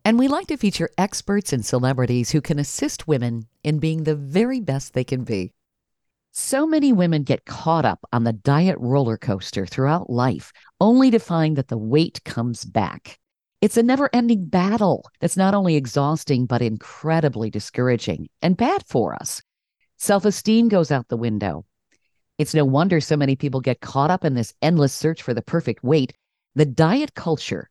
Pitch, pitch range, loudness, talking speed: 150 Hz, 125-185 Hz, -21 LUFS, 180 wpm